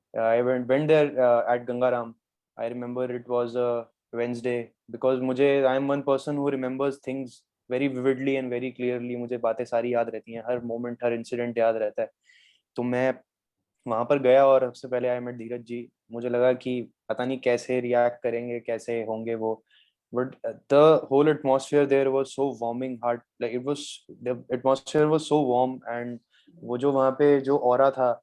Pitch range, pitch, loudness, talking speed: 120-135 Hz, 125 Hz, -25 LUFS, 195 wpm